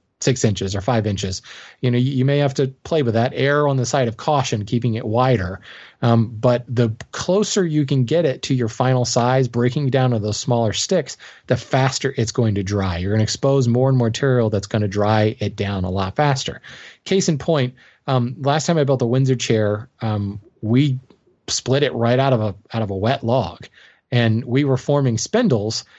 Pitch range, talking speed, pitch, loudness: 110-135 Hz, 215 wpm, 125 Hz, -19 LUFS